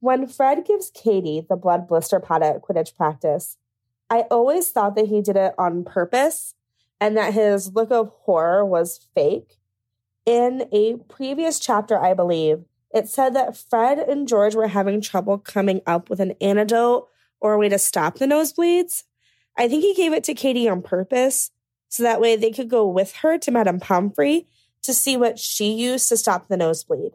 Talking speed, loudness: 185 wpm, -20 LUFS